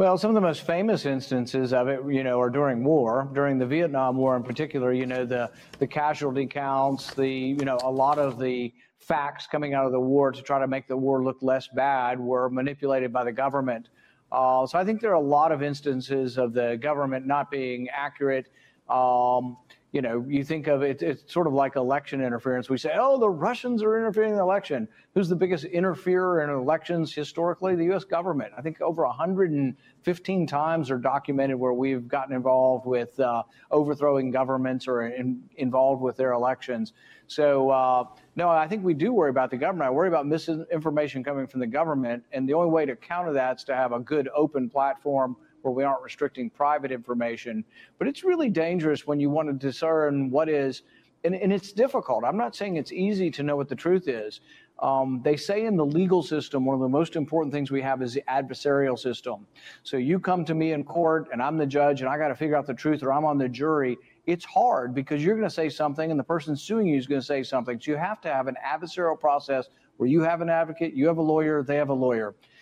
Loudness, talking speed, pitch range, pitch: -26 LUFS, 220 wpm, 130-160 Hz, 140 Hz